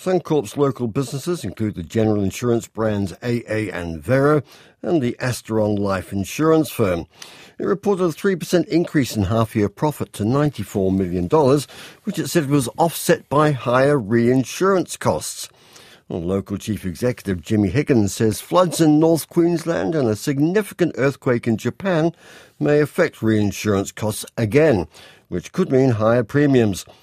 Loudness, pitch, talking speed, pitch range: -20 LUFS, 125 Hz, 140 wpm, 105-150 Hz